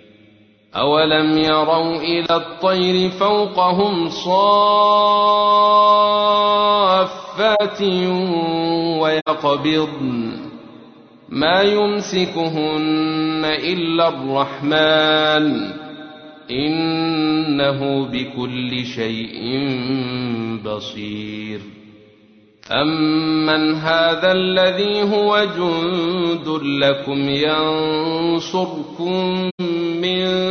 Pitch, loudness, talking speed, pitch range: 155 Hz, -17 LUFS, 45 wpm, 140-185 Hz